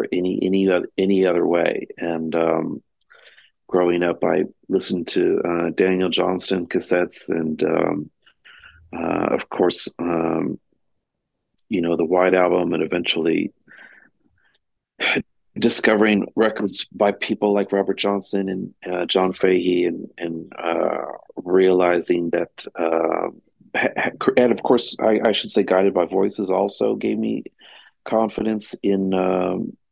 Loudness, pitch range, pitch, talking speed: -21 LUFS, 85-100 Hz, 90 Hz, 130 wpm